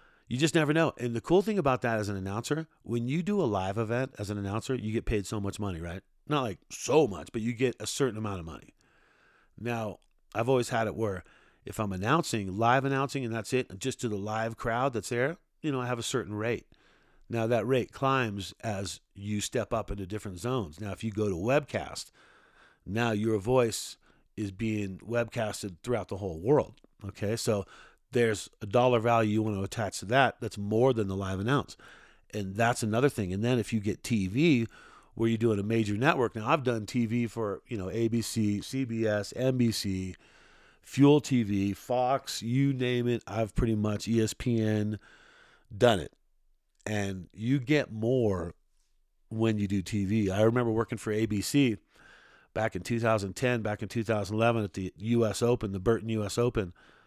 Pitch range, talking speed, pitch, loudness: 105-120 Hz, 190 wpm, 115 Hz, -30 LUFS